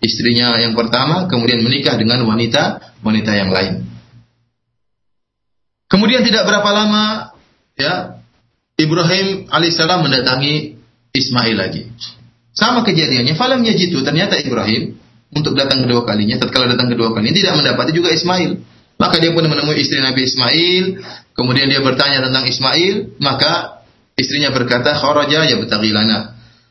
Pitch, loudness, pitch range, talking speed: 130 Hz, -13 LUFS, 115-165 Hz, 125 wpm